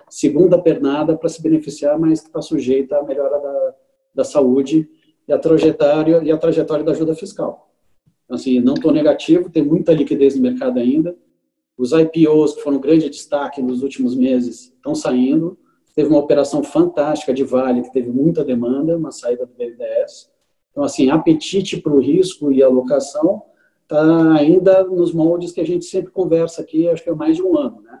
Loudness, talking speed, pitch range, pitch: -16 LUFS, 185 wpm, 145-190 Hz, 160 Hz